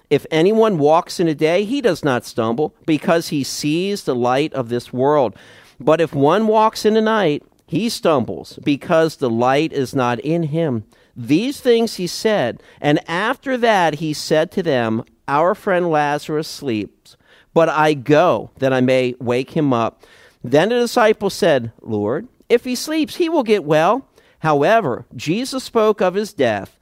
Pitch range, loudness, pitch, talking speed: 135-210 Hz, -18 LUFS, 155 Hz, 170 wpm